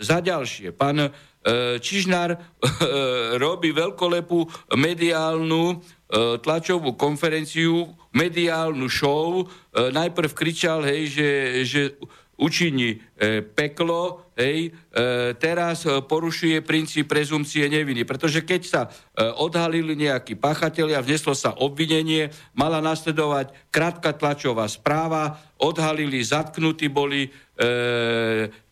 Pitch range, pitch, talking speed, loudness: 135-165 Hz, 155 Hz, 100 wpm, -23 LUFS